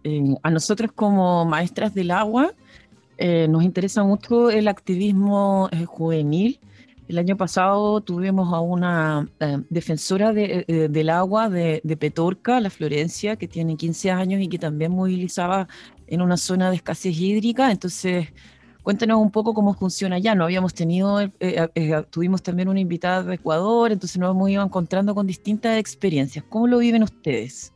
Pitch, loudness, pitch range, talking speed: 185 Hz, -21 LUFS, 165-205 Hz, 160 wpm